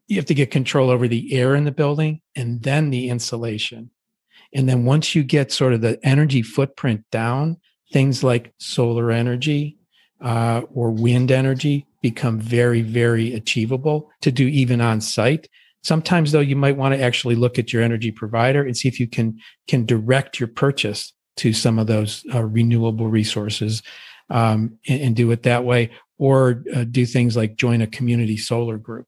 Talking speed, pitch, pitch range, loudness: 180 wpm, 125 Hz, 115-140 Hz, -19 LUFS